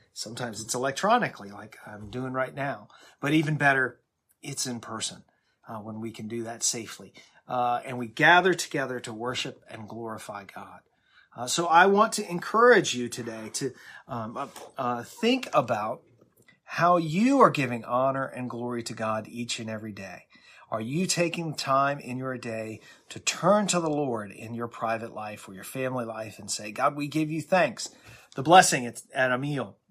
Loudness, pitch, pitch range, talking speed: -26 LUFS, 125 Hz, 115-150 Hz, 185 wpm